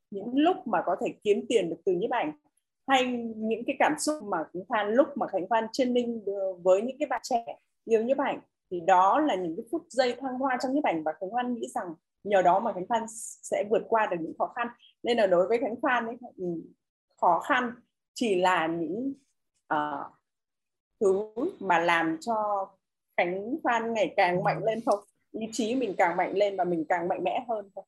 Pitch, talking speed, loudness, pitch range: 225 Hz, 215 wpm, -28 LUFS, 190-265 Hz